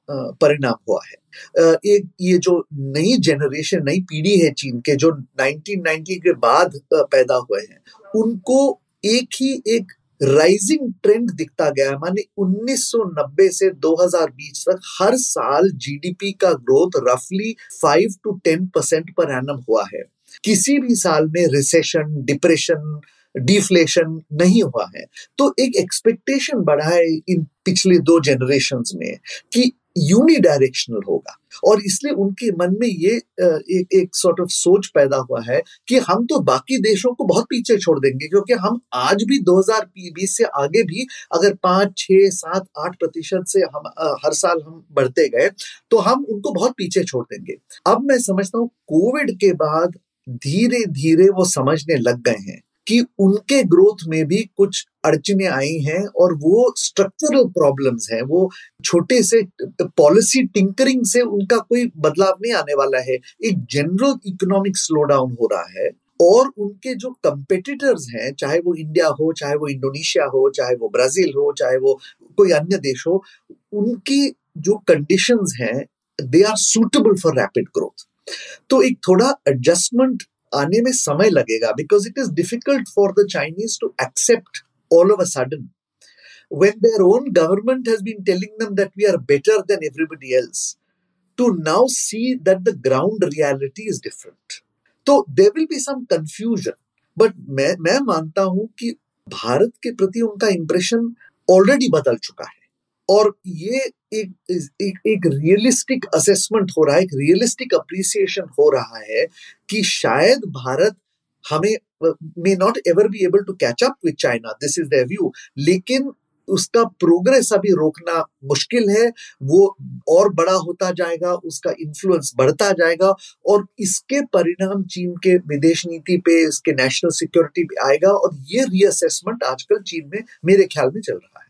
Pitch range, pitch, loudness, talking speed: 165-235 Hz, 195 Hz, -17 LUFS, 135 wpm